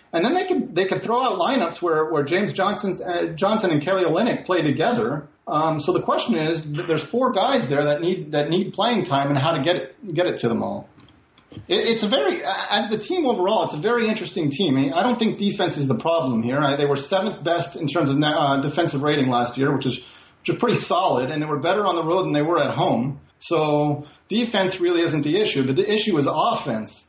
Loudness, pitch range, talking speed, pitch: -21 LUFS, 145-190 Hz, 235 wpm, 170 Hz